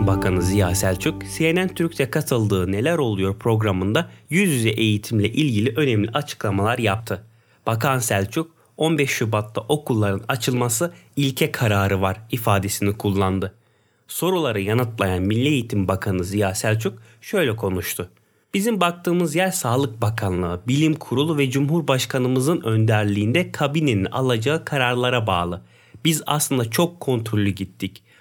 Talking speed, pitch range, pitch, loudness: 115 wpm, 100-145 Hz, 115 Hz, -21 LUFS